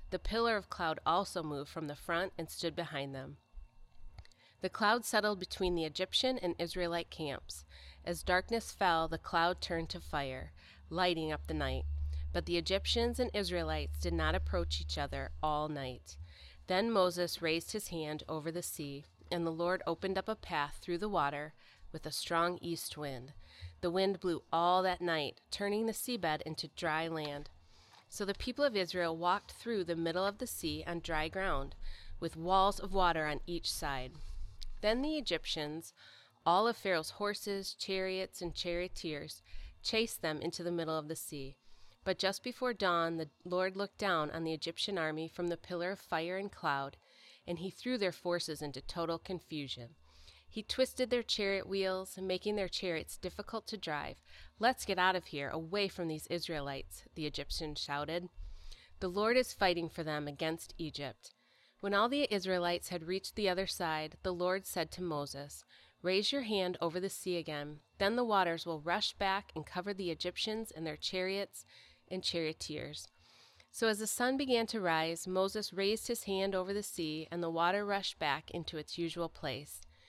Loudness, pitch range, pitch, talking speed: -36 LUFS, 150-195 Hz, 170 Hz, 180 wpm